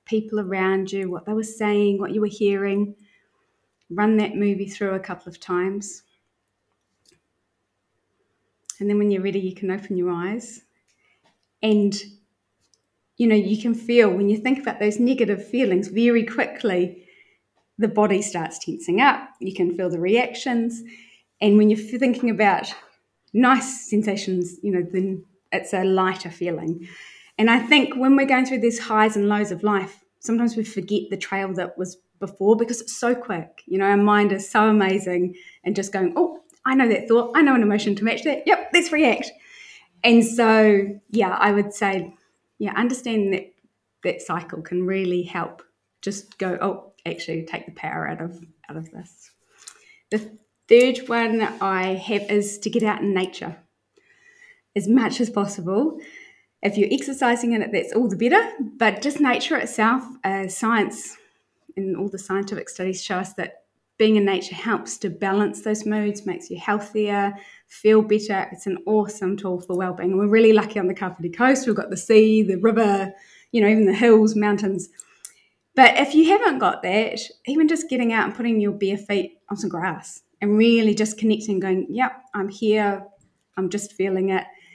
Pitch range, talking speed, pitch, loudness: 190-230 Hz, 180 wpm, 205 Hz, -21 LUFS